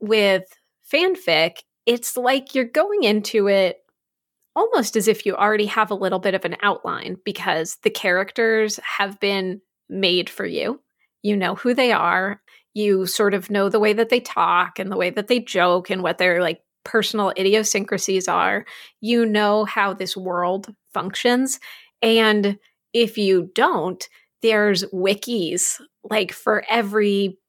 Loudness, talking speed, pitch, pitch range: -20 LUFS, 155 wpm, 205 Hz, 190-225 Hz